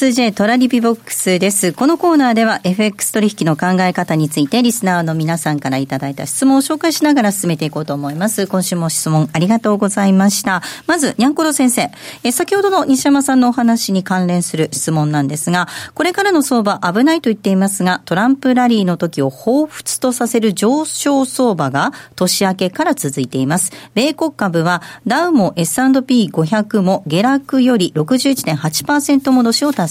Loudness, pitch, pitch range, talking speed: -14 LUFS, 210 Hz, 175-260 Hz, 380 characters per minute